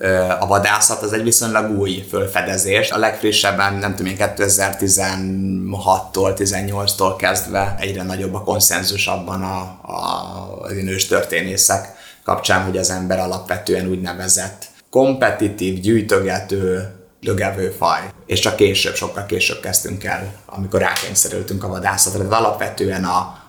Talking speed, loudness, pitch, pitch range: 120 wpm, -17 LUFS, 95 Hz, 95-100 Hz